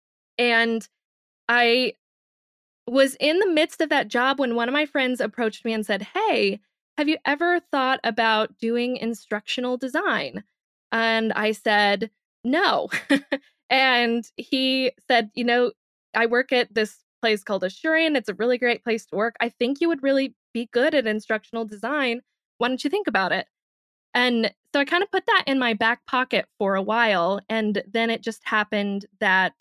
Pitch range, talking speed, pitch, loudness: 220-270 Hz, 175 wpm, 240 Hz, -23 LUFS